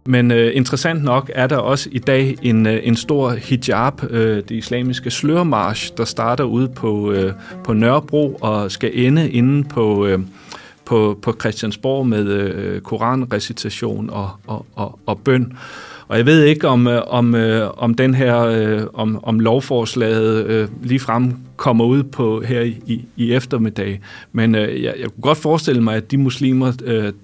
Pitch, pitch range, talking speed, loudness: 115 Hz, 110-130 Hz, 165 wpm, -17 LUFS